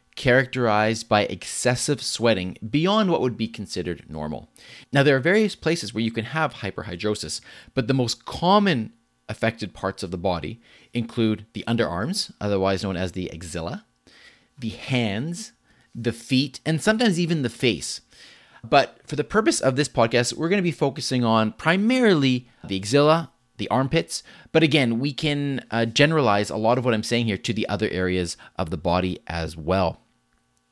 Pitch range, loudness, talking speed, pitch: 95-145 Hz, -23 LUFS, 170 wpm, 115 Hz